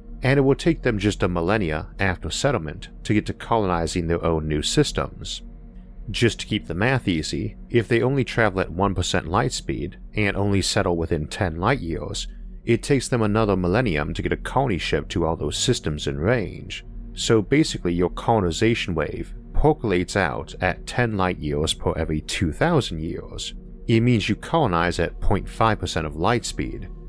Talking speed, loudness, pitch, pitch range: 175 wpm, -23 LUFS, 100 Hz, 85-115 Hz